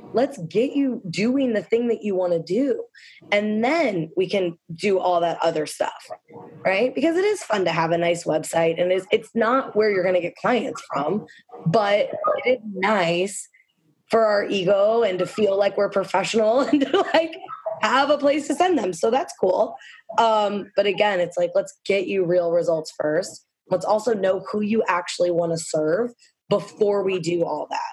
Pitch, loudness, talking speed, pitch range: 205 Hz, -22 LUFS, 195 wpm, 180-255 Hz